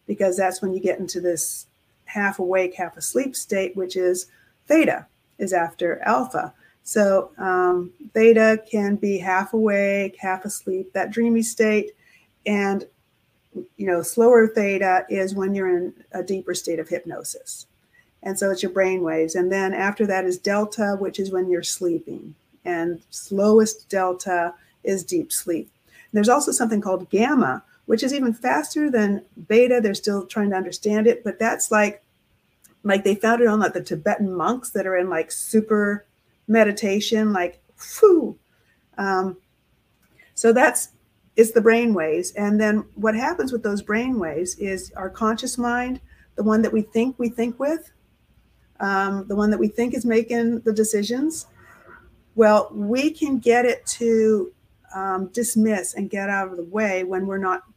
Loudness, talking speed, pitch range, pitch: -21 LUFS, 165 wpm, 185-230 Hz, 205 Hz